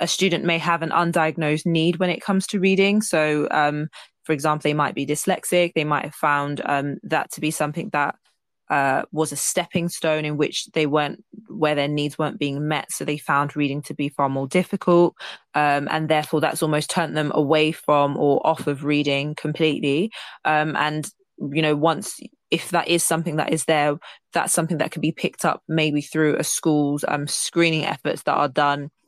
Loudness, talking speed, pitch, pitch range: -22 LUFS, 200 wpm, 155 Hz, 150-170 Hz